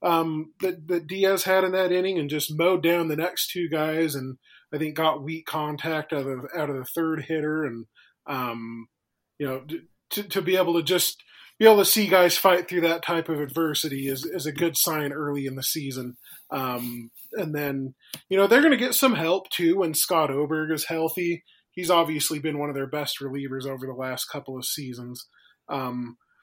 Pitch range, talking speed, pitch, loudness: 140-175 Hz, 205 wpm, 155 Hz, -24 LUFS